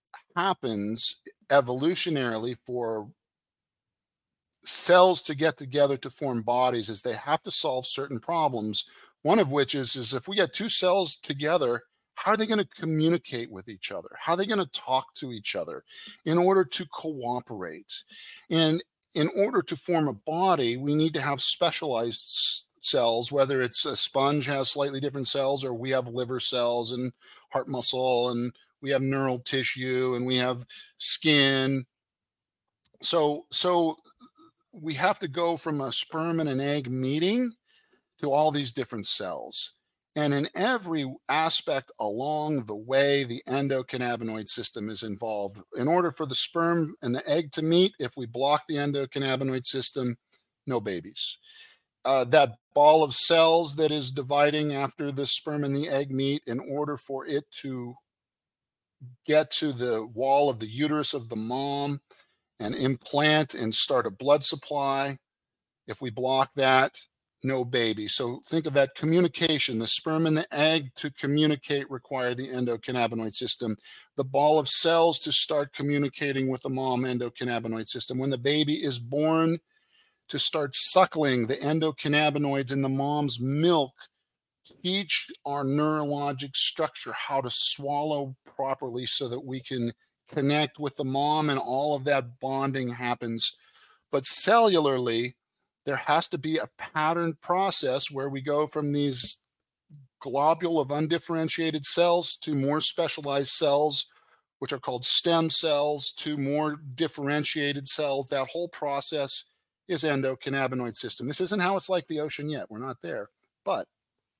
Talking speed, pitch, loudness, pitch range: 155 wpm, 140 Hz, -24 LUFS, 130-155 Hz